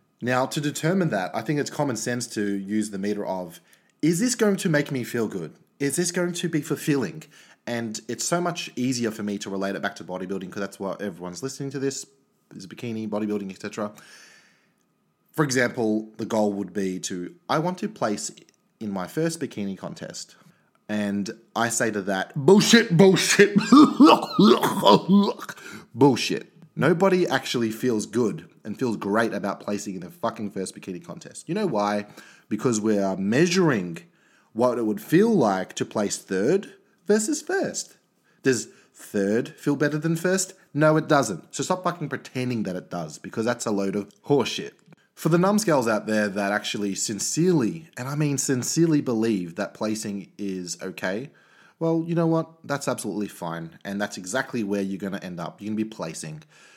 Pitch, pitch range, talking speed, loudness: 120 Hz, 105-165 Hz, 180 wpm, -24 LUFS